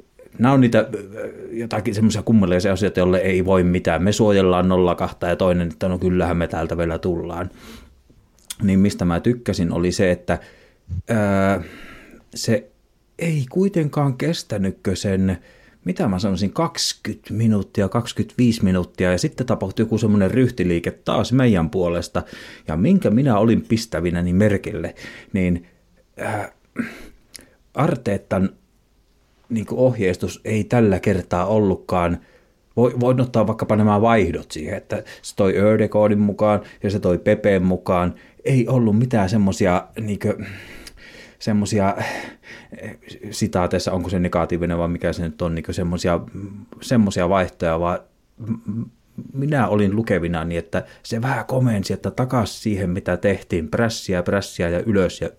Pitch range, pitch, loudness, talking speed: 90-110 Hz, 100 Hz, -20 LUFS, 130 wpm